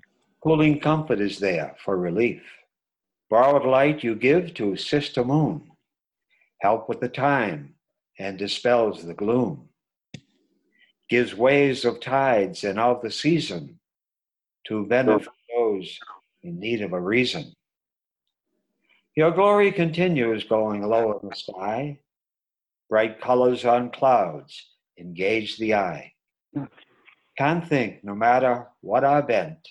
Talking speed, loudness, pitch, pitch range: 120 wpm, -23 LUFS, 125 Hz, 110-145 Hz